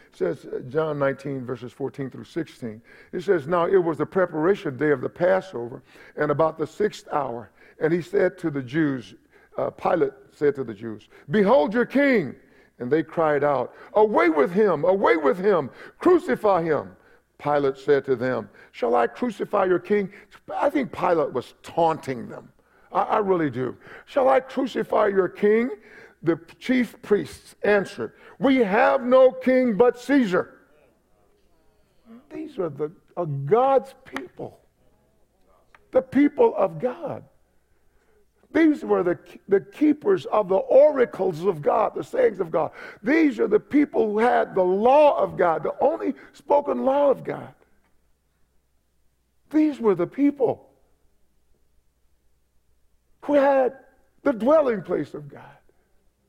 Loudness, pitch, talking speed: -22 LUFS, 190 Hz, 145 wpm